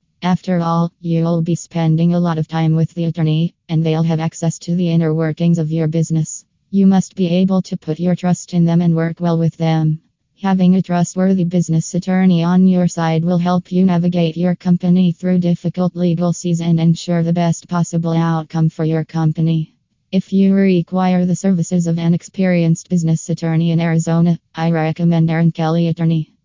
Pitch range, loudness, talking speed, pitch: 165-180 Hz, -16 LUFS, 185 wpm, 170 Hz